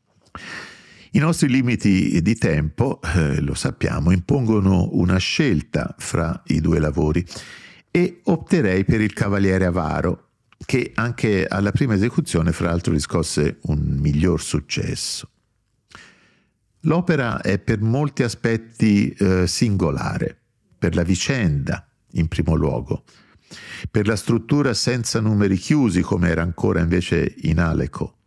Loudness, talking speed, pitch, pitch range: -20 LUFS, 120 wpm, 95 Hz, 85-115 Hz